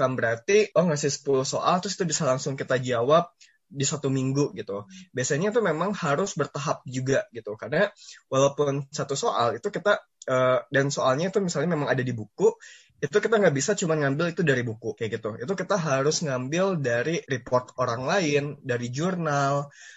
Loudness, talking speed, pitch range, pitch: -25 LUFS, 175 wpm, 130-185 Hz, 145 Hz